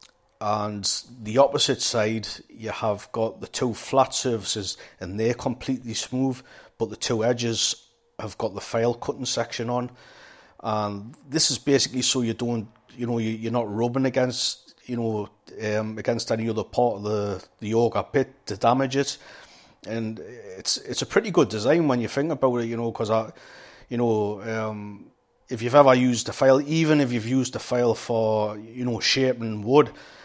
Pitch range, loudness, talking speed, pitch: 110-130 Hz, -24 LUFS, 175 wpm, 115 Hz